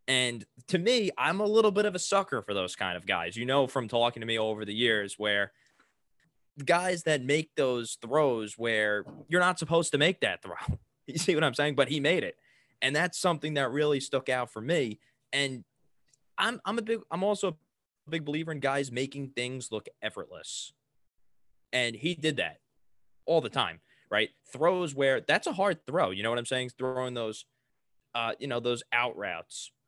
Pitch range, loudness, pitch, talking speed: 120-165 Hz, -29 LUFS, 135 Hz, 200 wpm